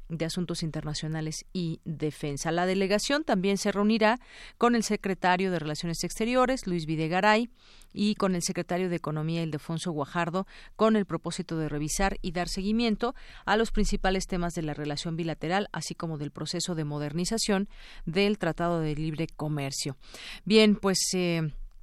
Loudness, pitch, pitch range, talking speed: -28 LUFS, 175 Hz, 160-200 Hz, 155 wpm